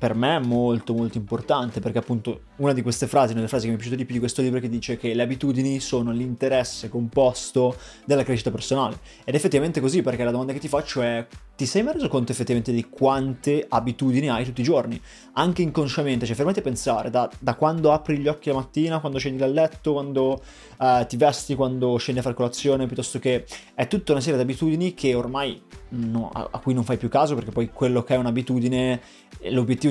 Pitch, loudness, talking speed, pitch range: 130 Hz, -24 LUFS, 225 wpm, 120-140 Hz